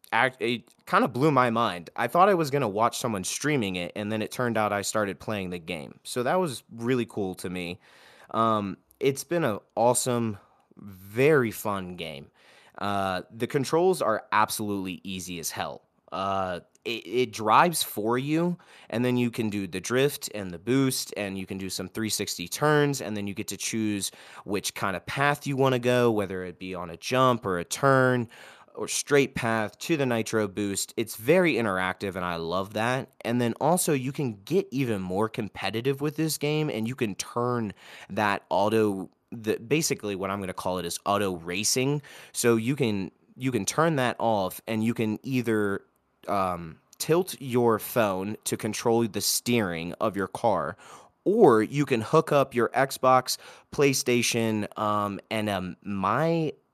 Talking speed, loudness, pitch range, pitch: 185 wpm, -27 LUFS, 100-130 Hz, 110 Hz